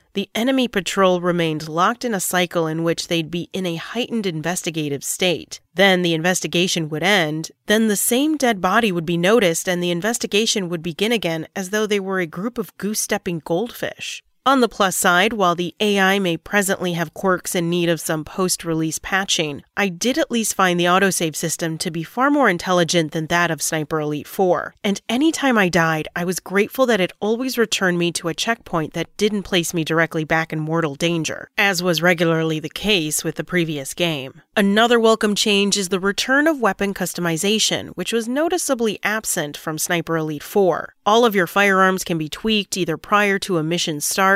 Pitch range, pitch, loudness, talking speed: 165-210 Hz, 185 Hz, -19 LUFS, 200 wpm